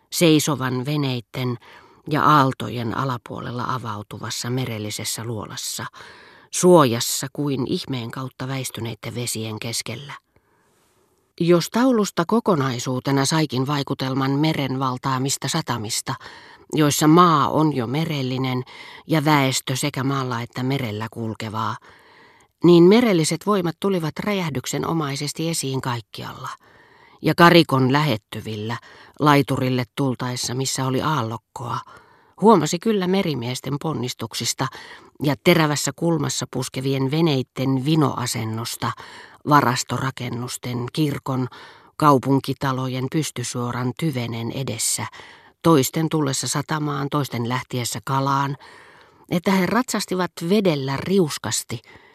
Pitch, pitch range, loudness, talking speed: 135 Hz, 125-155 Hz, -21 LUFS, 90 wpm